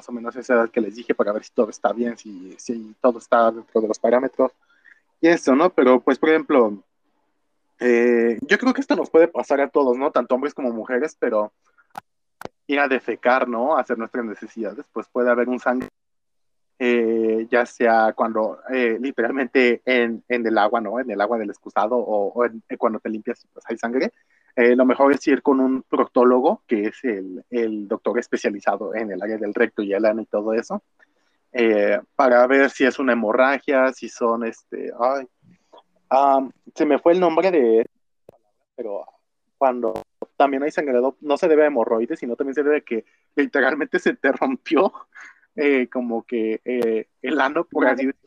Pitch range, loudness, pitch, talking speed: 115-135 Hz, -20 LUFS, 125 Hz, 195 wpm